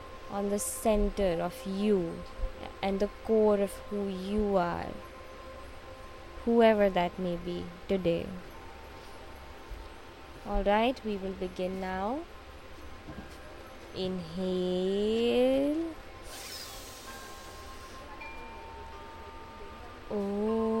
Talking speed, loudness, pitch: 70 wpm, -31 LUFS, 190 Hz